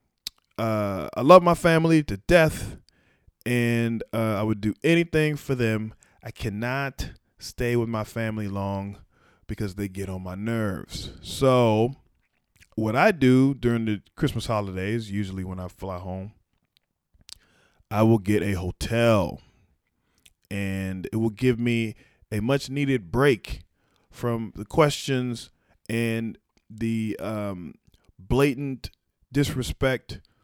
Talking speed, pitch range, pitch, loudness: 125 wpm, 100-125 Hz, 110 Hz, -24 LUFS